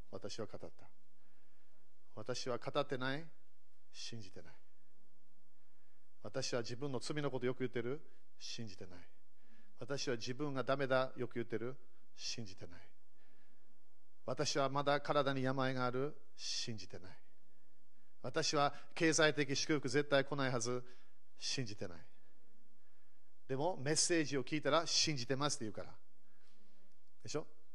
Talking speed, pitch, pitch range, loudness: 250 characters per minute, 130 Hz, 120-145 Hz, -39 LUFS